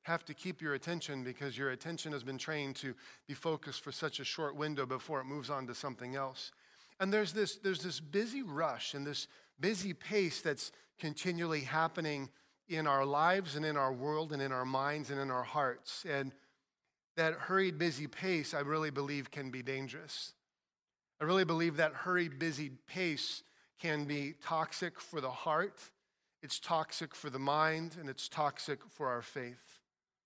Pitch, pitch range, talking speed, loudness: 150 Hz, 140-165 Hz, 180 wpm, -37 LUFS